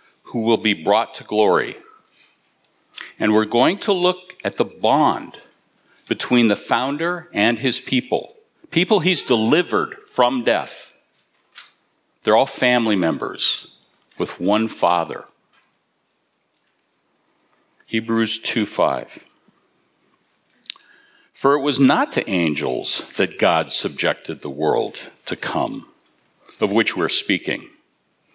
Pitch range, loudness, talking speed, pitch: 115-170 Hz, -20 LUFS, 110 wpm, 125 Hz